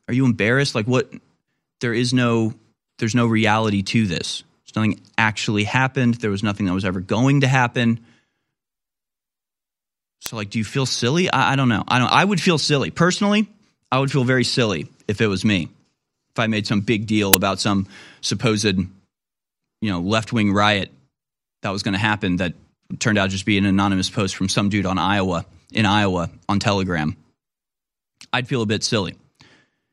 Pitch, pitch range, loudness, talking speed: 110 Hz, 100-120 Hz, -20 LUFS, 185 wpm